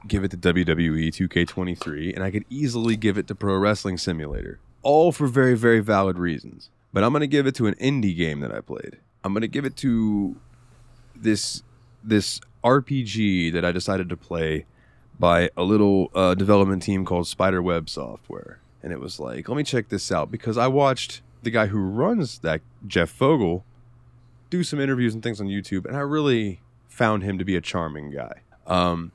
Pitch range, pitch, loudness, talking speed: 90-120 Hz, 105 Hz, -23 LUFS, 195 wpm